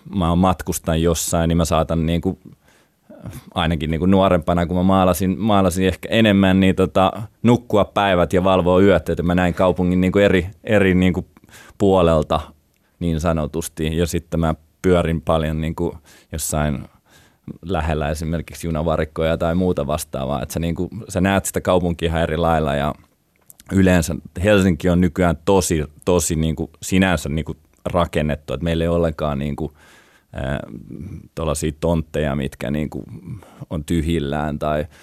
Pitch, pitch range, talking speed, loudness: 85 Hz, 80-95 Hz, 150 wpm, -19 LUFS